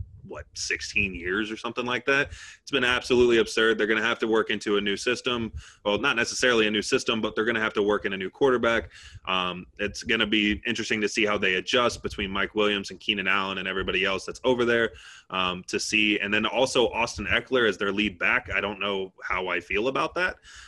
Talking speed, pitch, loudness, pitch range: 235 wpm, 105 Hz, -25 LUFS, 100-110 Hz